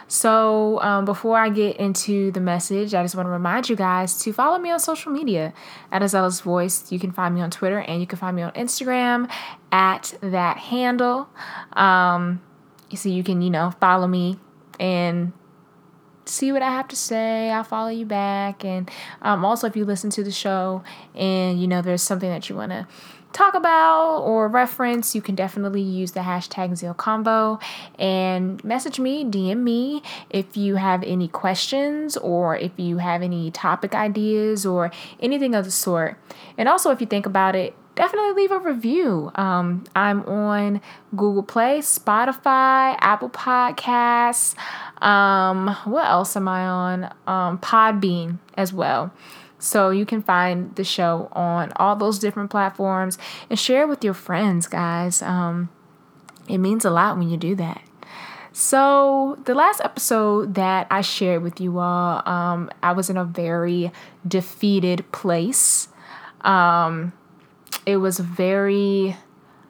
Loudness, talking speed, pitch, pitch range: -21 LUFS, 160 wpm, 195 Hz, 180-225 Hz